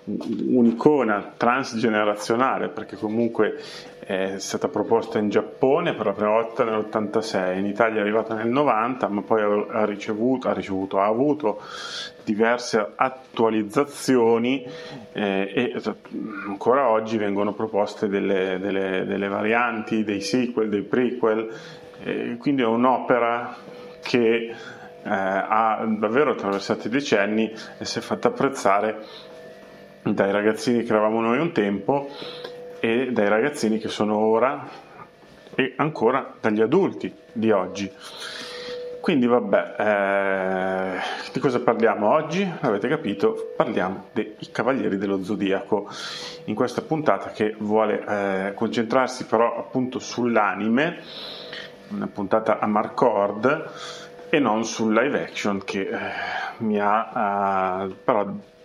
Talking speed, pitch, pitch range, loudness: 120 wpm, 110 Hz, 100-120 Hz, -23 LUFS